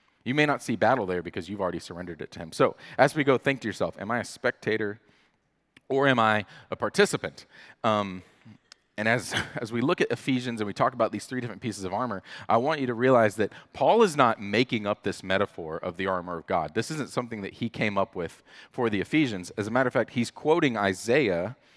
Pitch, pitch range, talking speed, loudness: 110 Hz, 100-130 Hz, 230 wpm, -27 LUFS